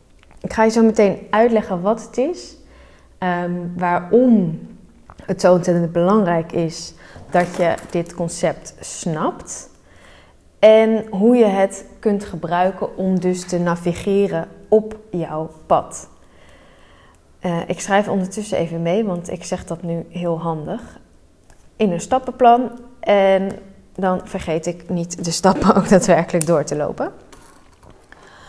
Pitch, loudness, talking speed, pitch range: 185 Hz, -18 LUFS, 125 wpm, 175-215 Hz